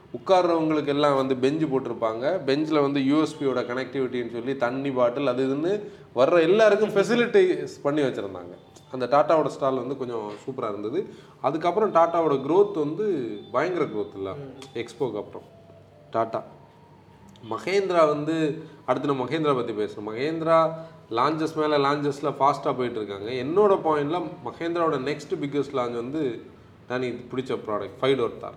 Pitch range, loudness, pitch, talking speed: 125-160 Hz, -25 LUFS, 145 Hz, 125 wpm